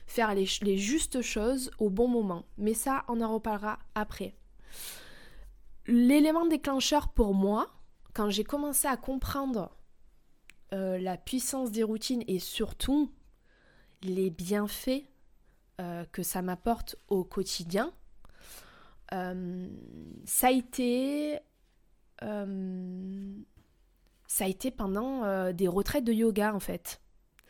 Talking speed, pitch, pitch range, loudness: 120 wpm, 215 Hz, 190-255 Hz, -31 LUFS